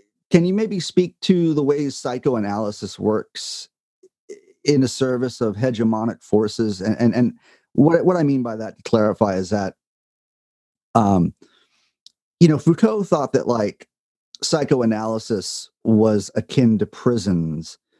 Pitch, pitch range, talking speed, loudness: 120 Hz, 110-165 Hz, 135 wpm, -20 LUFS